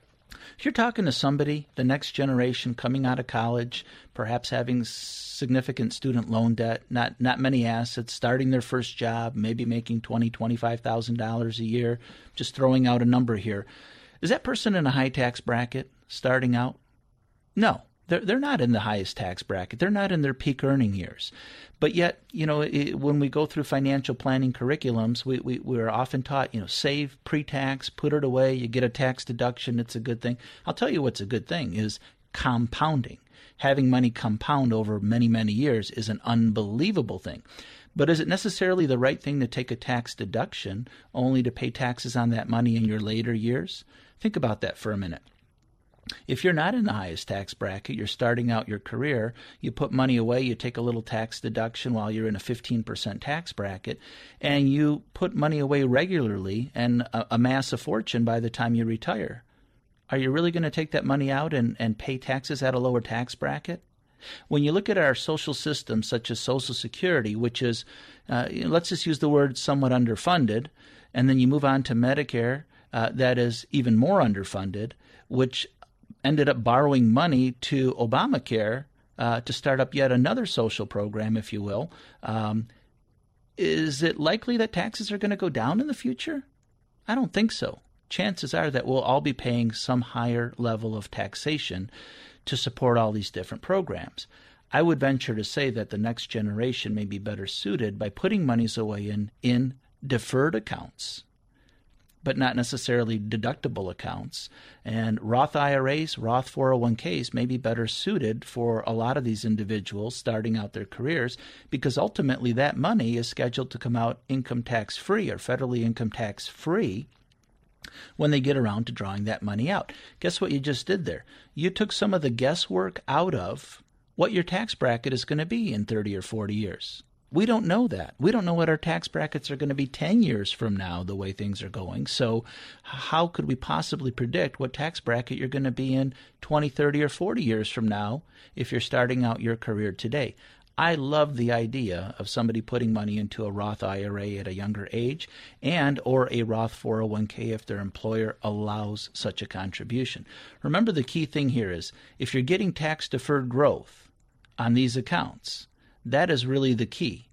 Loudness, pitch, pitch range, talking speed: -27 LUFS, 125 Hz, 115-140 Hz, 190 wpm